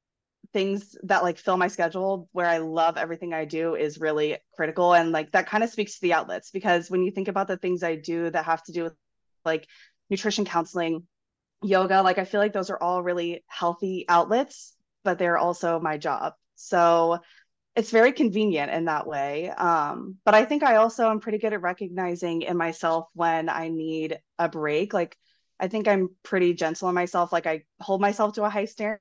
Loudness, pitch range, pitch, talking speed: -25 LUFS, 165-200 Hz, 175 Hz, 205 wpm